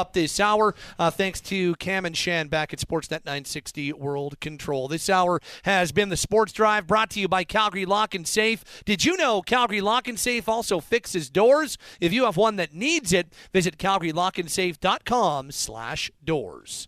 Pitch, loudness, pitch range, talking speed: 190 Hz, -24 LUFS, 165-215 Hz, 180 wpm